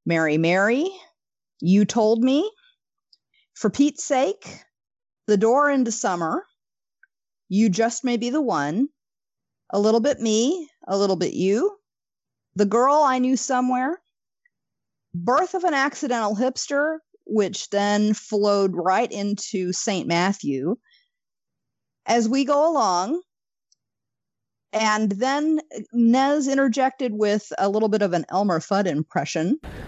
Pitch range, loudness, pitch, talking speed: 205-285 Hz, -22 LUFS, 235 Hz, 120 wpm